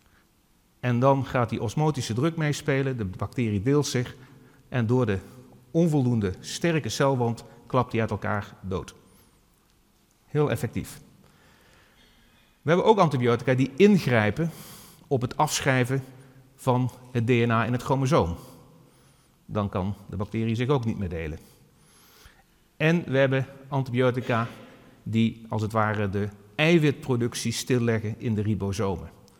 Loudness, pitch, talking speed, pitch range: -26 LUFS, 125 Hz, 125 wpm, 110-135 Hz